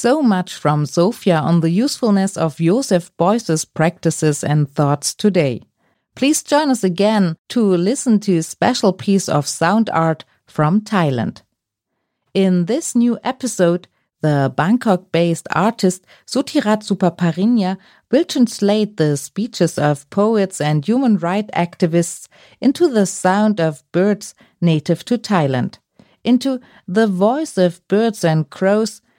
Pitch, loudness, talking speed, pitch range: 190 Hz, -17 LUFS, 125 wpm, 165-220 Hz